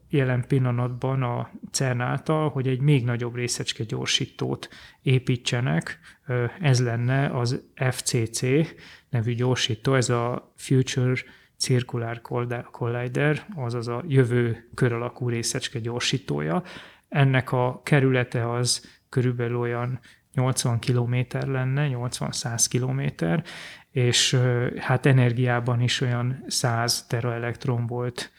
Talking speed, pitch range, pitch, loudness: 105 wpm, 120-130 Hz, 125 Hz, -25 LUFS